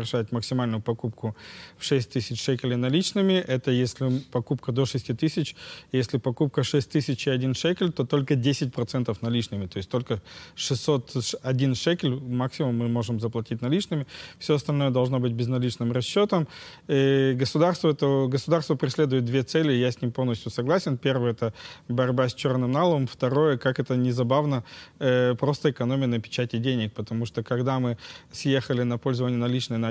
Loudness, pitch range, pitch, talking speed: -26 LUFS, 120-140 Hz, 130 Hz, 155 wpm